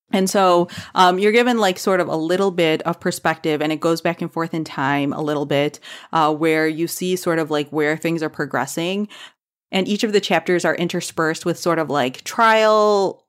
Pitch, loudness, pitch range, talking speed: 170 Hz, -19 LUFS, 155-190 Hz, 210 wpm